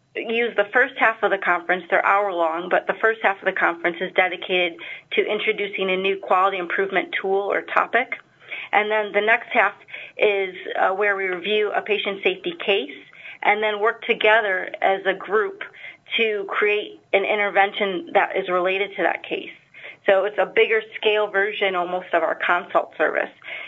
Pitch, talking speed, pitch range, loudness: 200 Hz, 175 wpm, 185-220 Hz, -21 LUFS